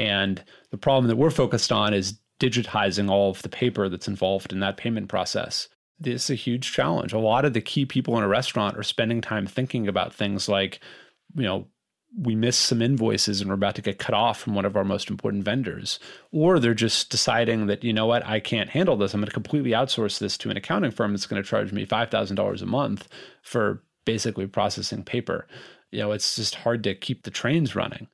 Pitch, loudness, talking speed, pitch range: 110 Hz, -25 LUFS, 225 wpm, 100-120 Hz